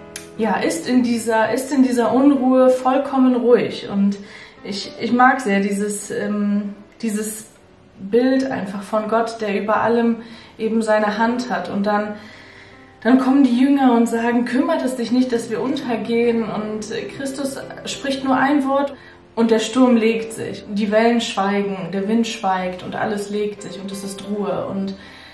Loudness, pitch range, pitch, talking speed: -19 LUFS, 205-250 Hz, 225 Hz, 170 wpm